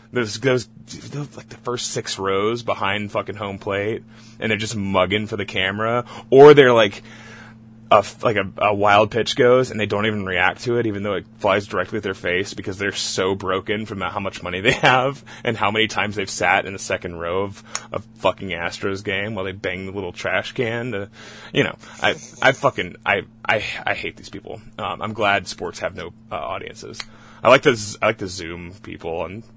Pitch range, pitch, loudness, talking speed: 100-115 Hz, 105 Hz, -20 LUFS, 215 wpm